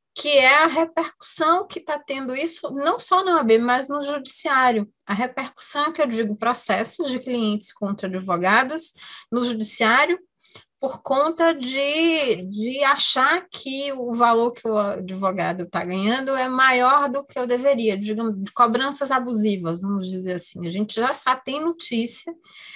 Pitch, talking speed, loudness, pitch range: 255 Hz, 155 wpm, -21 LUFS, 220-290 Hz